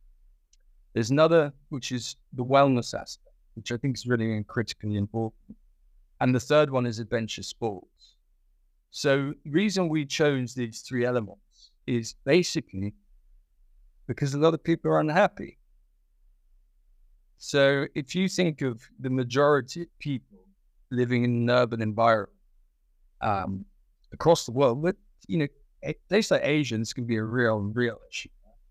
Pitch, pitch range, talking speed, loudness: 120 Hz, 100-145 Hz, 140 wpm, -26 LUFS